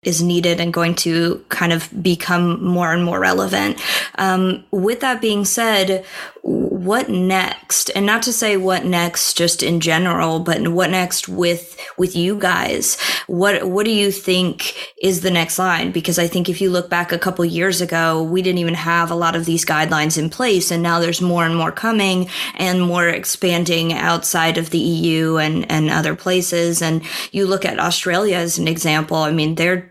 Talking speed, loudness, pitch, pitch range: 190 wpm, -17 LUFS, 175 Hz, 165-185 Hz